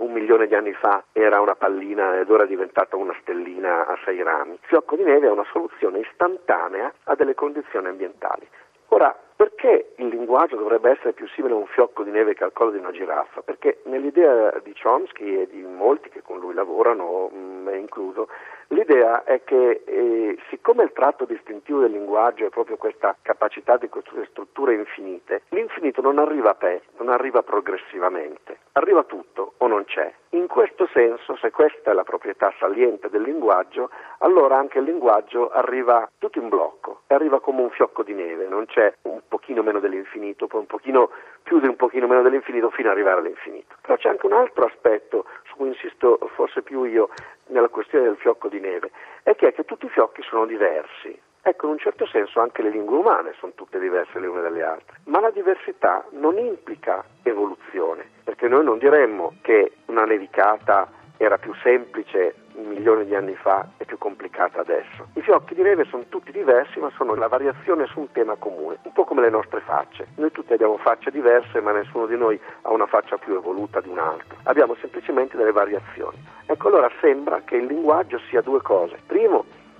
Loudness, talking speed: -21 LUFS, 190 wpm